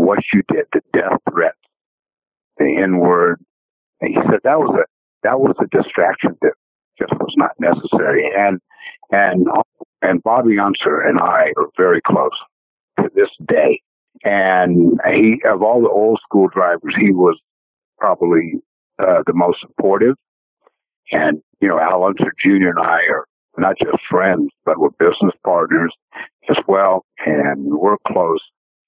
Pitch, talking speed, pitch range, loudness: 390 Hz, 150 wpm, 290-445 Hz, -15 LUFS